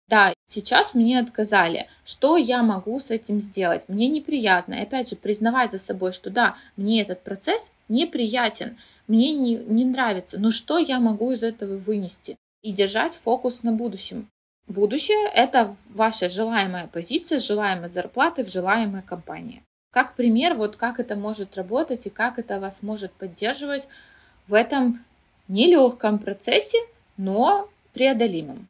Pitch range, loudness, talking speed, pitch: 200-255 Hz, -22 LUFS, 145 wpm, 230 Hz